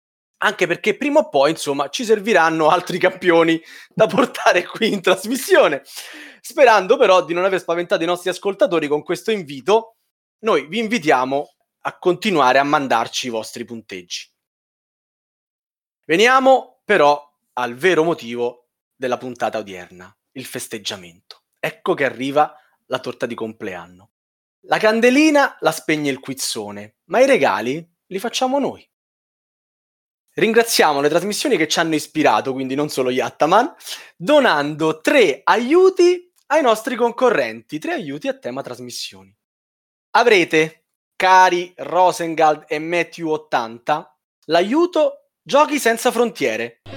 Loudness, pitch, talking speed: -18 LUFS, 165 Hz, 125 wpm